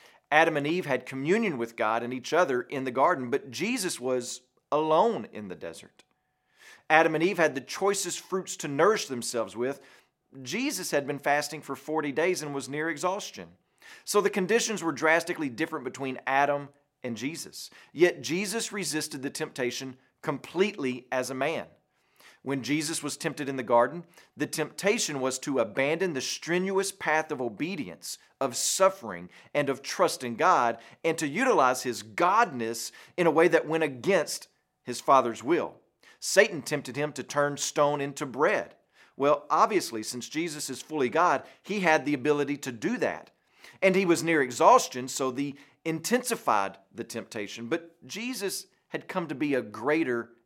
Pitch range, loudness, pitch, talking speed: 130-165 Hz, -28 LUFS, 145 Hz, 165 wpm